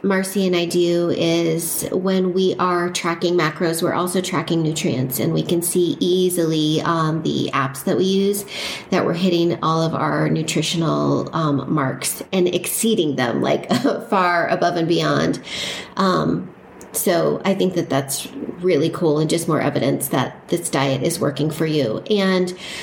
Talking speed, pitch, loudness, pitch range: 165 wpm, 170 Hz, -19 LUFS, 155-180 Hz